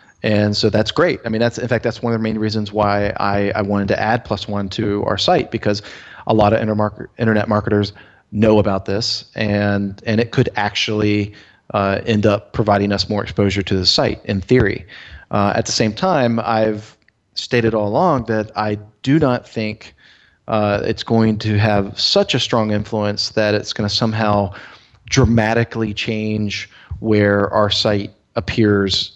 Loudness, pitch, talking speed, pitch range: -17 LUFS, 105 Hz, 180 wpm, 100-115 Hz